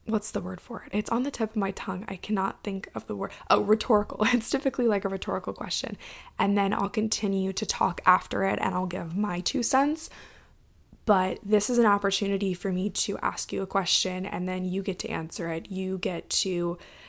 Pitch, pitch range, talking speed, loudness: 200 Hz, 190-215 Hz, 220 wpm, -27 LUFS